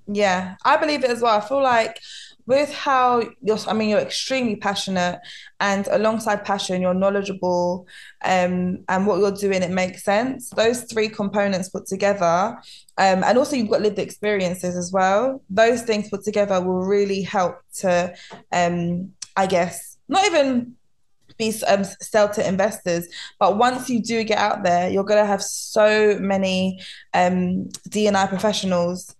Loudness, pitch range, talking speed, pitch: -21 LUFS, 185-220 Hz, 160 wpm, 200 Hz